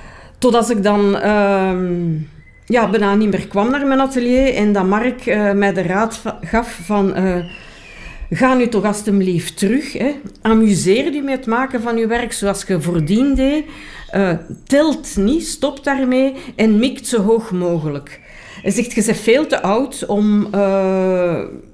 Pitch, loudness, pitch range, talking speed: 215 Hz, -16 LUFS, 195-250 Hz, 165 wpm